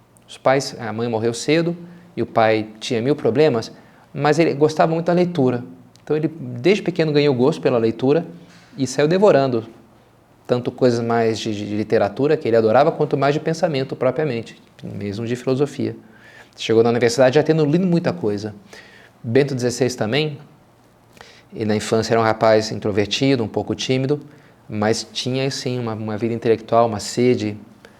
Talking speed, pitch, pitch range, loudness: 165 wpm, 125 Hz, 110-145 Hz, -19 LUFS